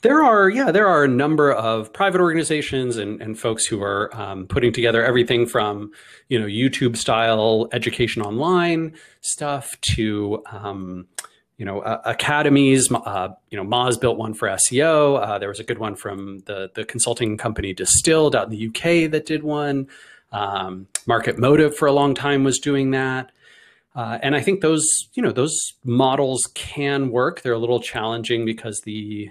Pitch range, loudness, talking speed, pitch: 110-140 Hz, -20 LUFS, 180 wpm, 120 Hz